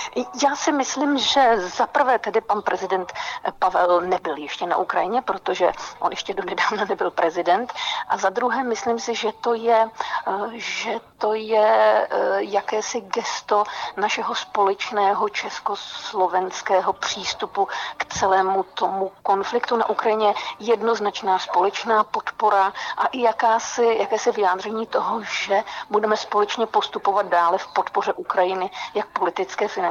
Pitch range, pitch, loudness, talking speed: 190-230 Hz, 215 Hz, -22 LUFS, 130 wpm